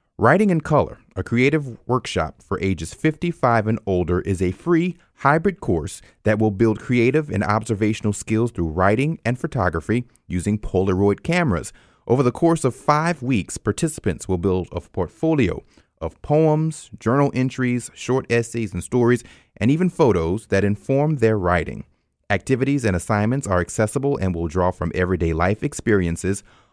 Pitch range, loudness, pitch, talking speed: 95-135 Hz, -21 LUFS, 110 Hz, 155 wpm